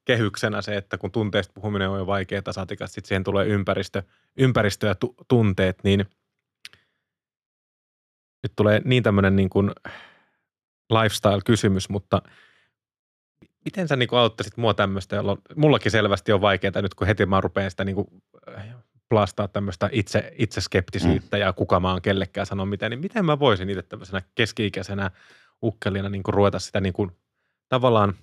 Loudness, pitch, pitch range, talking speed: -23 LUFS, 100 Hz, 95-110 Hz, 145 wpm